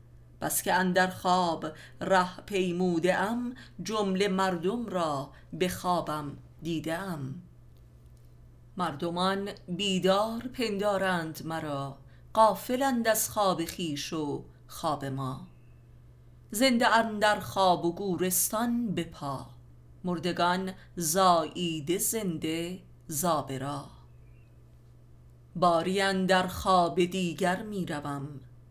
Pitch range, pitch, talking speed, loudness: 135-190 Hz, 175 Hz, 85 wpm, -29 LUFS